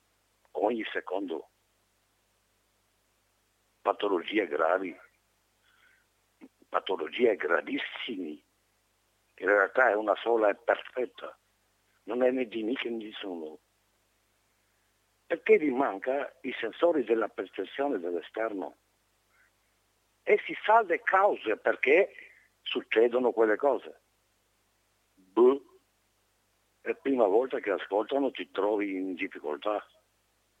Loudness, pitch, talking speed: -29 LUFS, 115 Hz, 95 wpm